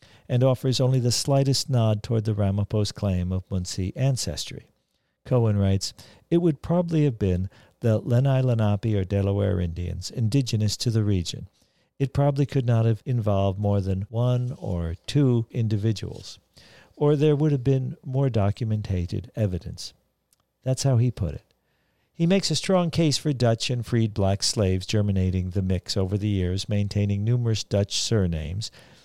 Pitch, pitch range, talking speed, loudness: 110 Hz, 100-130 Hz, 155 wpm, -24 LUFS